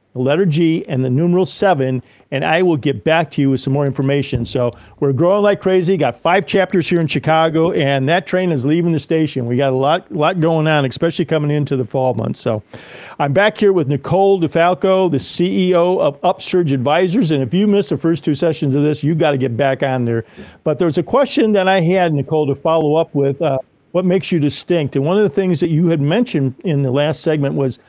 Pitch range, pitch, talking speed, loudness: 140-180 Hz, 160 Hz, 230 wpm, -16 LUFS